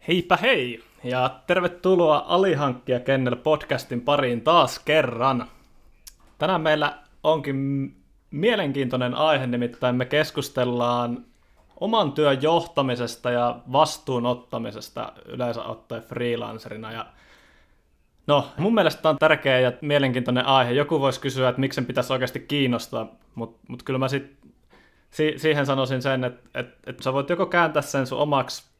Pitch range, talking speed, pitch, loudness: 125-150 Hz, 135 wpm, 135 Hz, -23 LUFS